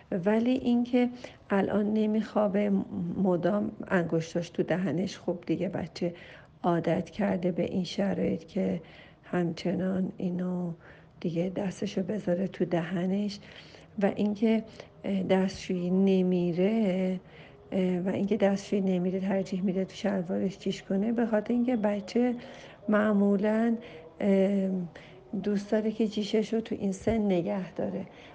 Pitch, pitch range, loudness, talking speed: 195 Hz, 180-210 Hz, -29 LUFS, 110 wpm